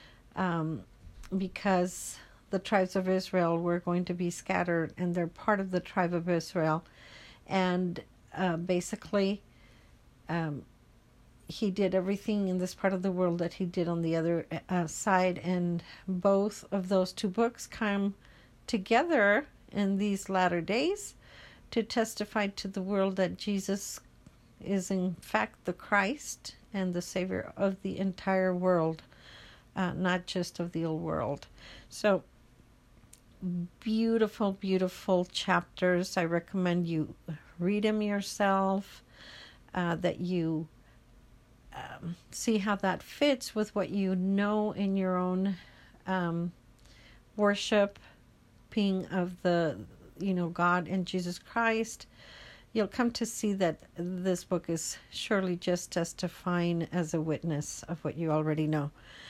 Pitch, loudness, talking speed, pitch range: 185 Hz, -31 LUFS, 135 wpm, 170-195 Hz